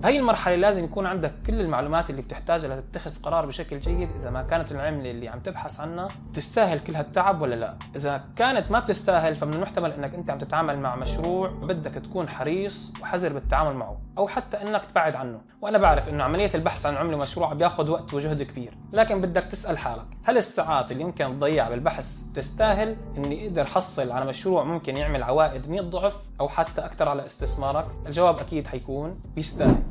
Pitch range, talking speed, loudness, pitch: 140-190 Hz, 185 wpm, -26 LUFS, 165 Hz